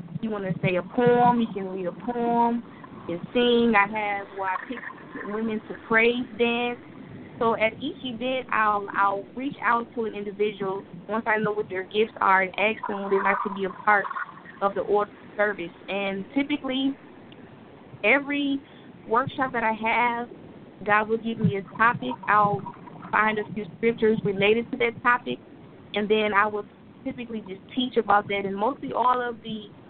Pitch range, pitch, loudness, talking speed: 200-240 Hz, 215 Hz, -25 LUFS, 185 wpm